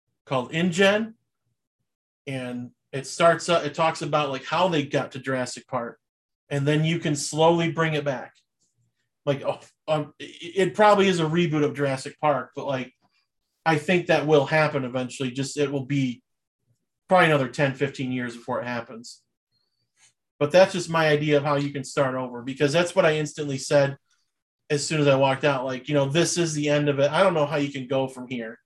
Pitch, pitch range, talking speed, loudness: 145 Hz, 135-160 Hz, 200 wpm, -23 LUFS